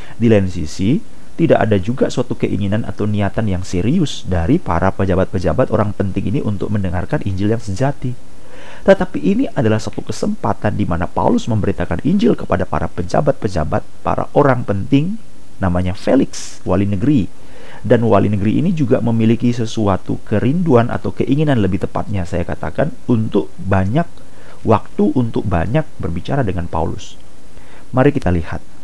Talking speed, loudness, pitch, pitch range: 140 wpm, -17 LUFS, 105 Hz, 95-120 Hz